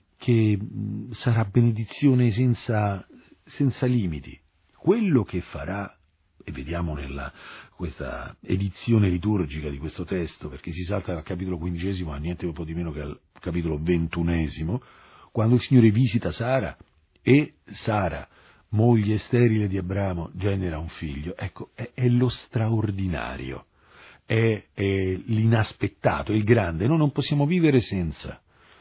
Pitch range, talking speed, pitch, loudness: 85-115 Hz, 135 wpm, 100 Hz, -25 LUFS